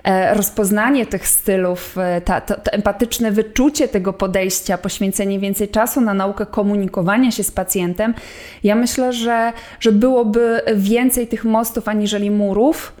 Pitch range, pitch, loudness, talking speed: 195-230 Hz, 210 Hz, -17 LUFS, 135 wpm